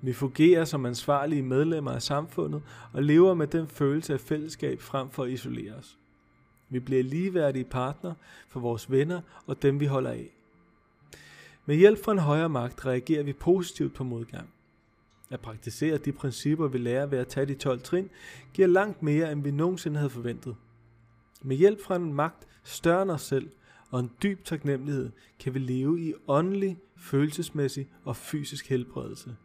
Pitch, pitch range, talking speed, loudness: 145 Hz, 130-165 Hz, 170 wpm, -28 LUFS